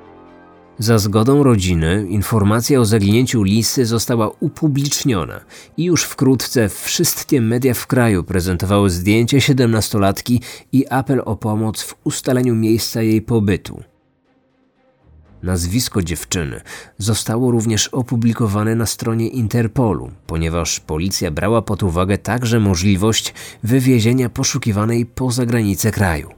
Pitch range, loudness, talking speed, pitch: 100-125 Hz, -17 LUFS, 110 wpm, 110 Hz